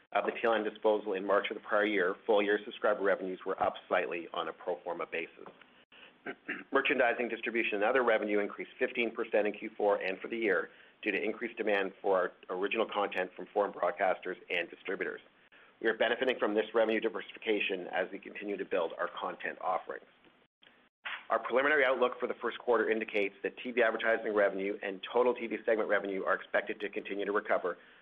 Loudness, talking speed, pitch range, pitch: -32 LUFS, 185 wpm, 100-115 Hz, 105 Hz